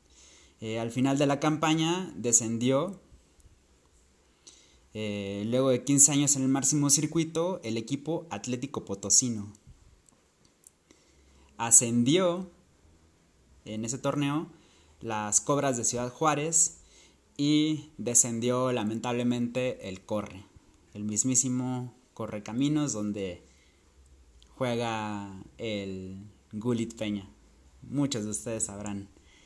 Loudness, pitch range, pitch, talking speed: -27 LUFS, 95-135 Hz, 115 Hz, 95 wpm